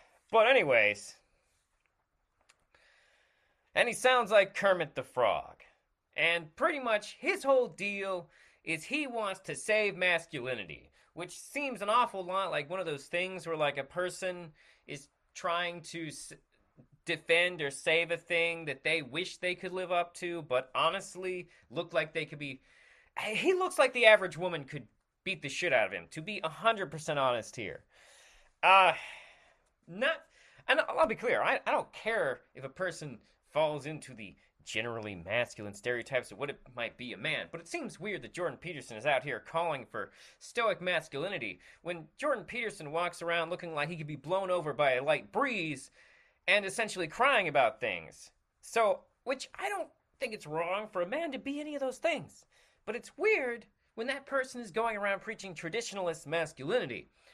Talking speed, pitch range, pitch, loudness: 175 wpm, 155-215 Hz, 175 Hz, -32 LUFS